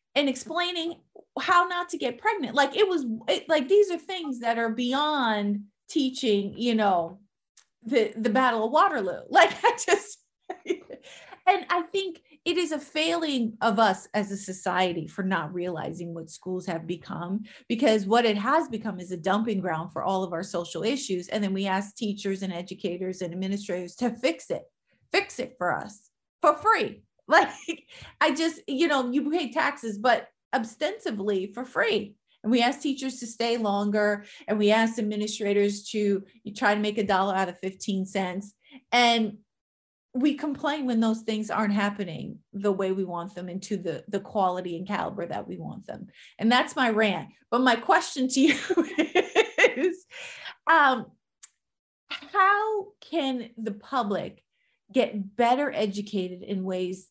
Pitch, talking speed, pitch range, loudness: 225 Hz, 165 wpm, 200-300 Hz, -26 LUFS